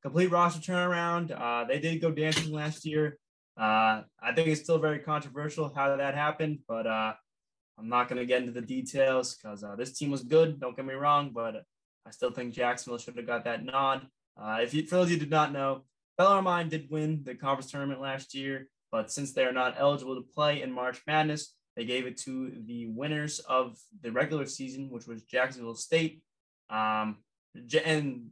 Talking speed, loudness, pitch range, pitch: 200 wpm, -30 LUFS, 120-155 Hz, 135 Hz